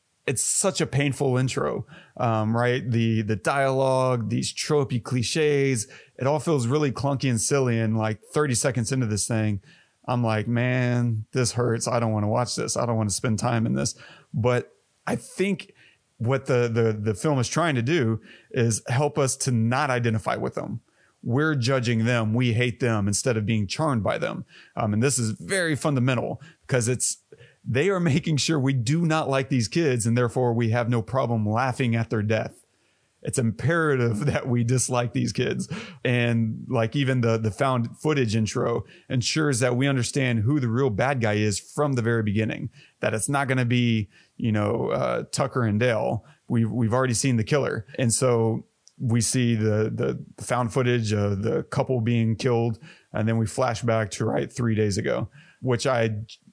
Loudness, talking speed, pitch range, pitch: -24 LUFS, 190 wpm, 115-135 Hz, 125 Hz